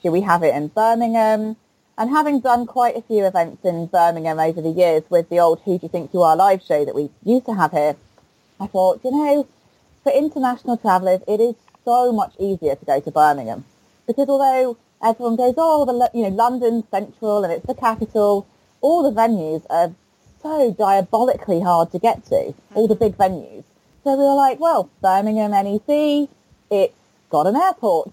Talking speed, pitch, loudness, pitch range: 190 wpm, 220 Hz, -18 LUFS, 180-250 Hz